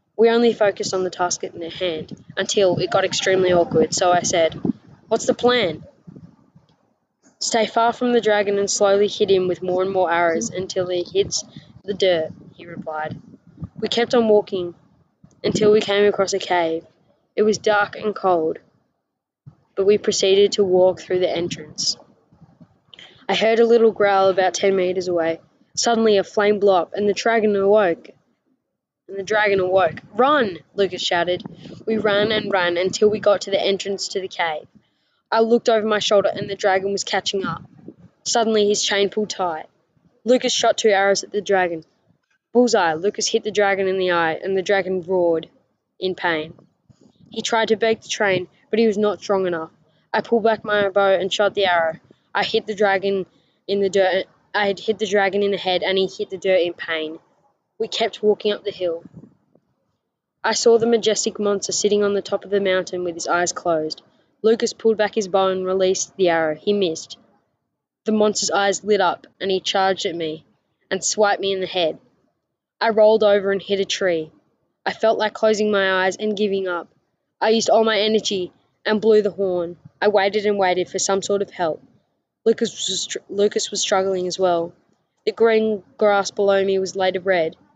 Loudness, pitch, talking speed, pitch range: -20 LUFS, 195 Hz, 190 wpm, 185-215 Hz